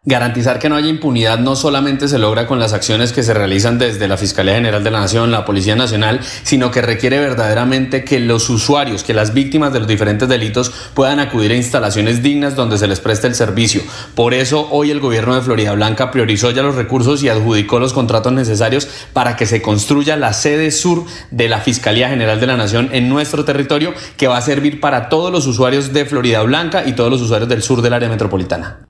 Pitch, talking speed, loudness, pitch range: 125 Hz, 215 wpm, -14 LUFS, 110-140 Hz